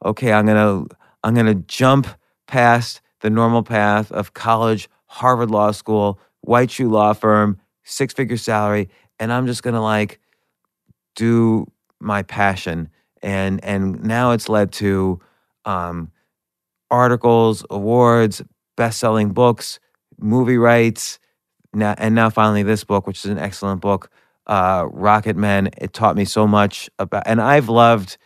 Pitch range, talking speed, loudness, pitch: 100-115 Hz, 140 wpm, -17 LUFS, 110 Hz